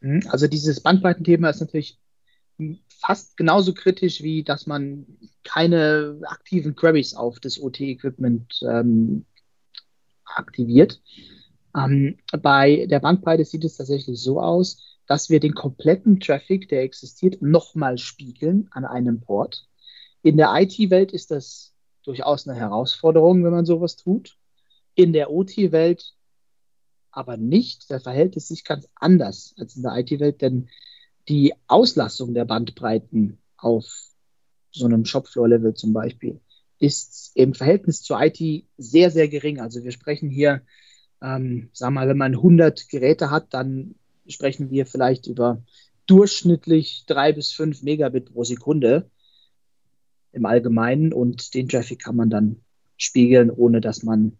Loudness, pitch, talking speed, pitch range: -20 LUFS, 140 Hz, 135 wpm, 125-160 Hz